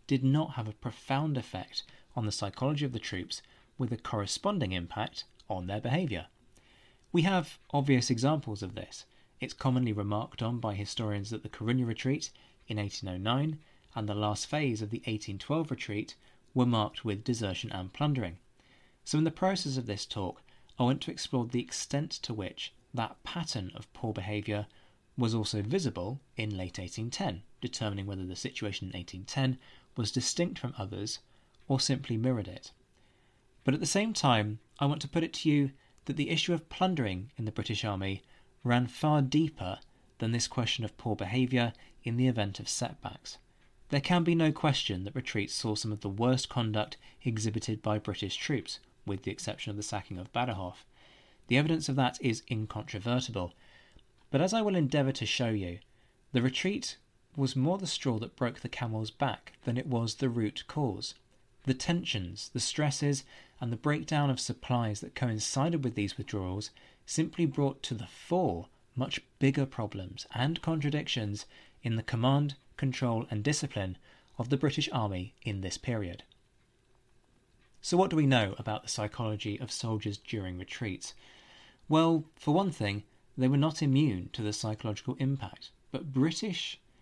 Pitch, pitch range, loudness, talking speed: 120 Hz, 105-135 Hz, -33 LUFS, 170 wpm